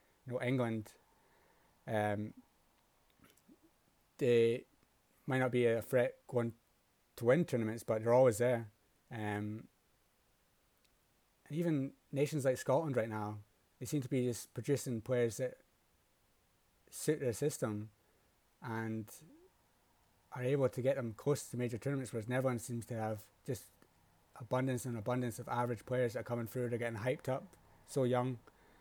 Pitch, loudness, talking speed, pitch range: 120 Hz, -37 LUFS, 145 wpm, 110-130 Hz